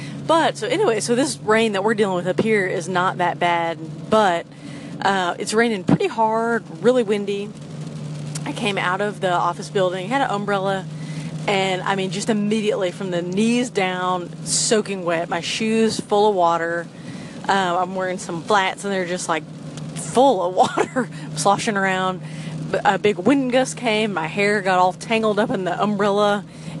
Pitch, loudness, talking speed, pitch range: 190 Hz, -20 LUFS, 175 wpm, 170-215 Hz